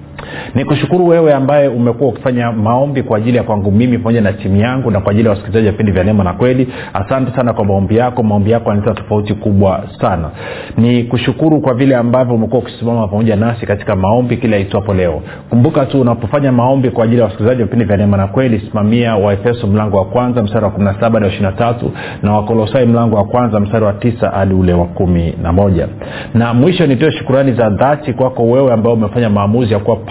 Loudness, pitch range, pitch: -12 LUFS, 105-125 Hz, 115 Hz